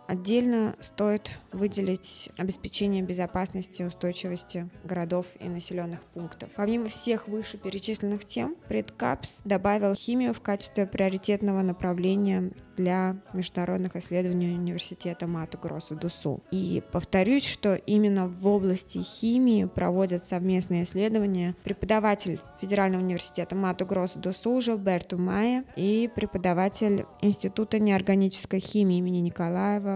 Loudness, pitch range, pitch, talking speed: -28 LUFS, 180-205 Hz, 190 Hz, 110 wpm